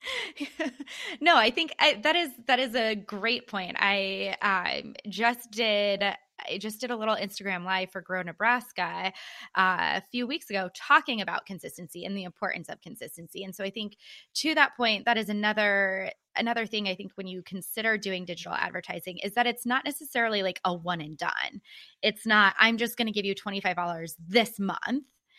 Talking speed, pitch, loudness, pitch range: 185 wpm, 210 Hz, -27 LUFS, 190-245 Hz